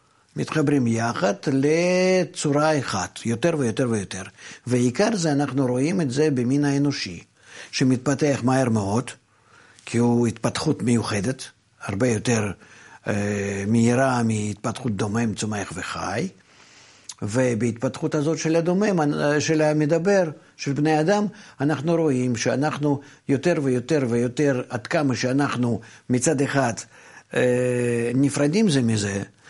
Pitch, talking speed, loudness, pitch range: 130 Hz, 110 wpm, -23 LUFS, 115-150 Hz